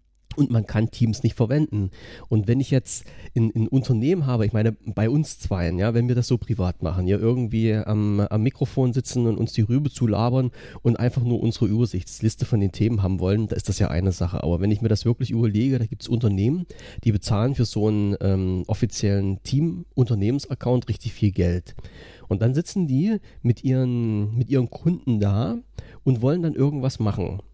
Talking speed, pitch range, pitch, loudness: 195 wpm, 105-125 Hz, 115 Hz, -23 LUFS